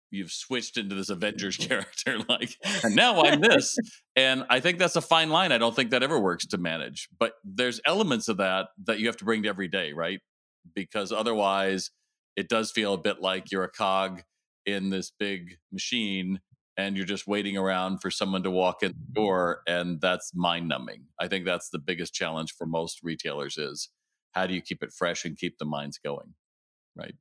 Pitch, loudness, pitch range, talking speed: 95 Hz, -27 LUFS, 90-115 Hz, 205 wpm